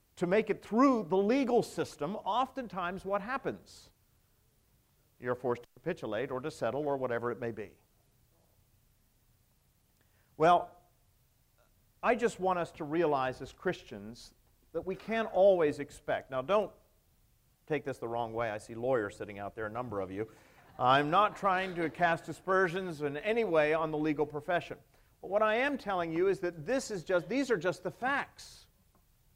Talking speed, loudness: 170 wpm, -32 LUFS